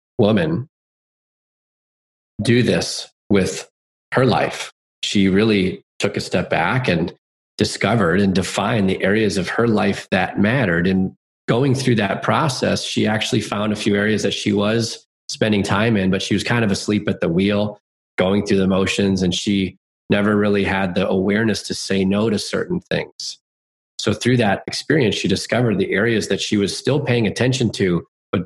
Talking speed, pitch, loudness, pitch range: 170 wpm, 100 Hz, -19 LUFS, 95-110 Hz